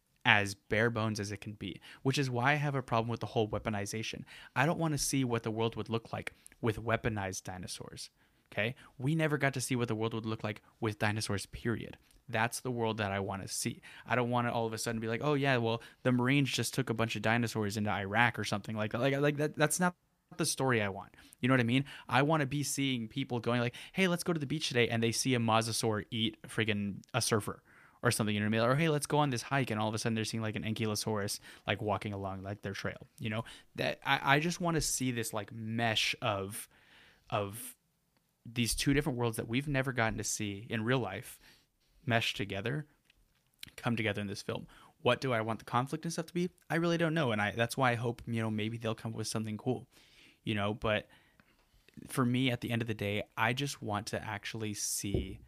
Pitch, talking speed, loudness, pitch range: 115 Hz, 245 wpm, -33 LUFS, 110-135 Hz